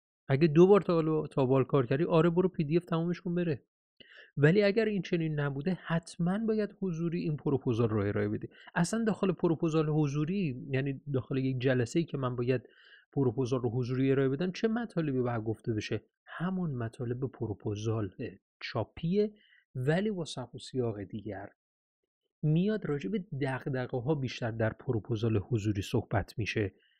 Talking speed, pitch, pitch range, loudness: 160 wpm, 140 Hz, 120-170 Hz, -31 LUFS